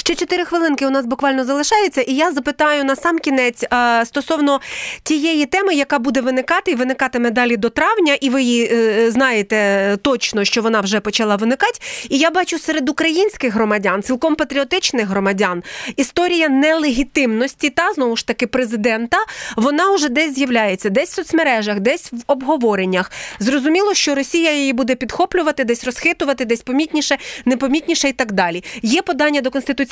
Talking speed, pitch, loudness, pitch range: 160 wpm, 275 Hz, -16 LUFS, 235-315 Hz